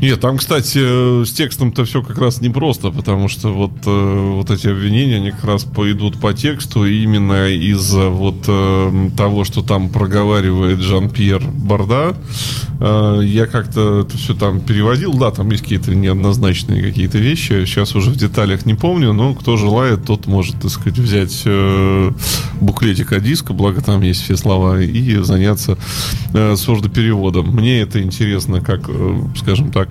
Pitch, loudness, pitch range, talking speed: 105 Hz, -15 LUFS, 100-120 Hz, 155 wpm